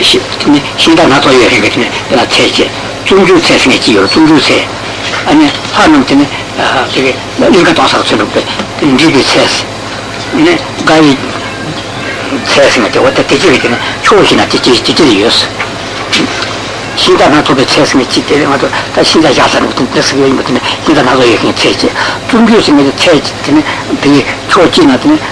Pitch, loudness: 140 Hz, -7 LUFS